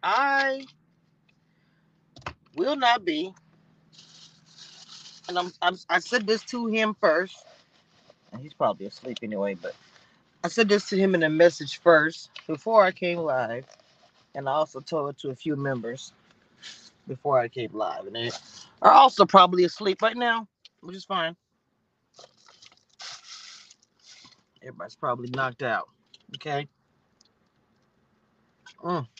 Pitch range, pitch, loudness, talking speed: 155-200 Hz, 175 Hz, -24 LUFS, 125 wpm